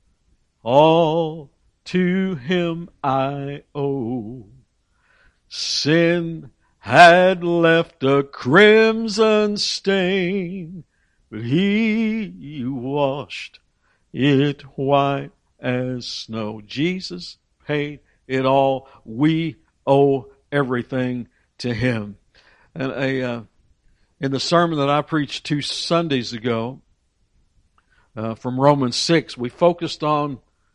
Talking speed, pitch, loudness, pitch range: 90 wpm, 140 Hz, -19 LUFS, 125-170 Hz